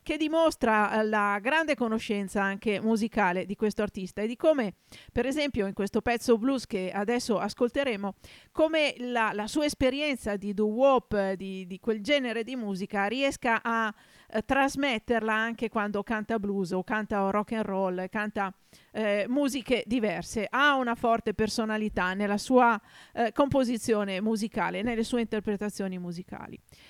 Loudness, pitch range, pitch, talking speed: -28 LUFS, 205-245 Hz, 220 Hz, 145 wpm